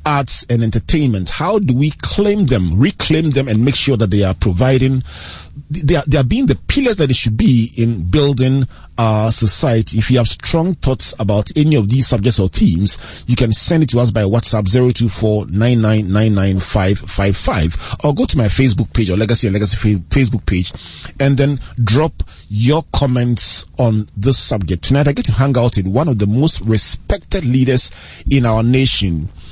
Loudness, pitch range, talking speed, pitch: -15 LUFS, 100-135 Hz, 205 wpm, 115 Hz